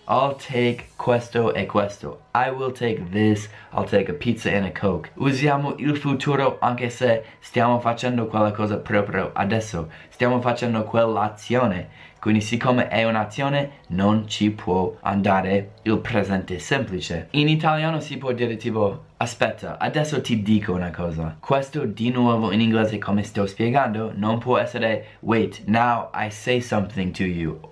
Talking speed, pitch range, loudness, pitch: 155 wpm, 105-125 Hz, -23 LUFS, 110 Hz